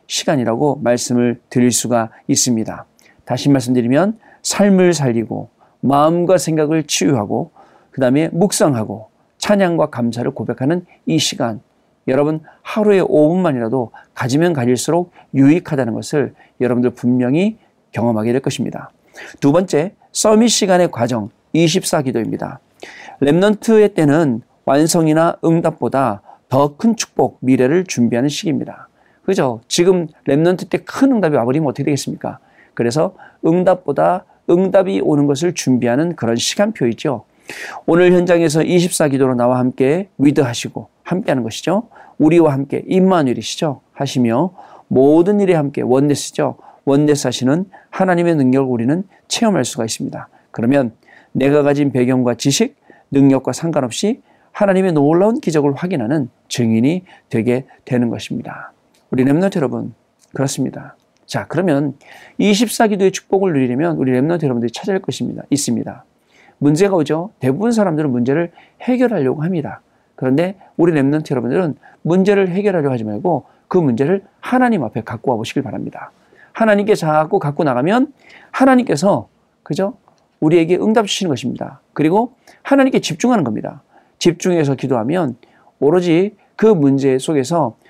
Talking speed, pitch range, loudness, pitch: 335 characters per minute, 130-185 Hz, -16 LUFS, 155 Hz